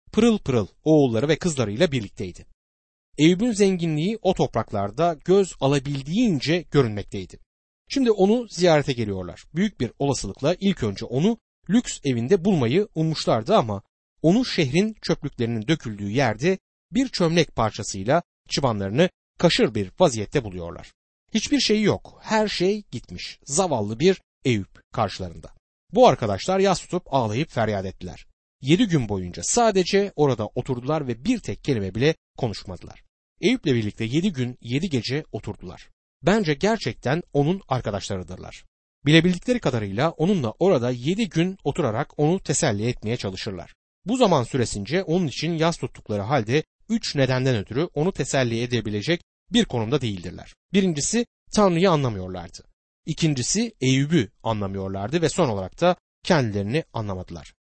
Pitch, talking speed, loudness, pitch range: 140 Hz, 125 wpm, -23 LUFS, 105-180 Hz